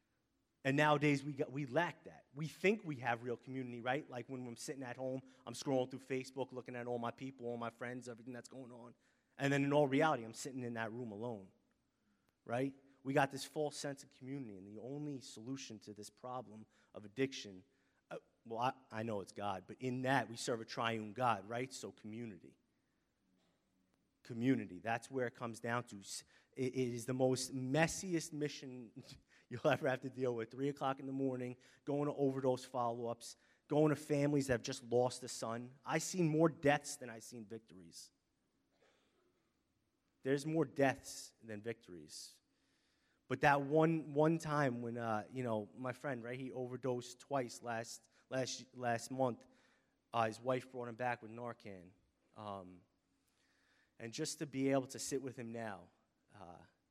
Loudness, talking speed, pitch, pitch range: -40 LUFS, 180 wpm, 125 Hz, 115-135 Hz